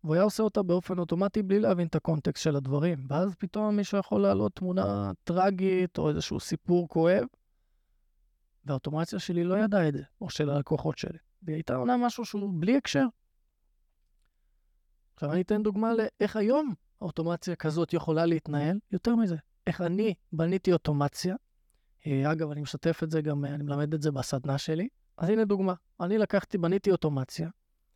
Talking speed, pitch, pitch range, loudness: 160 wpm, 165 Hz, 145-195 Hz, -29 LUFS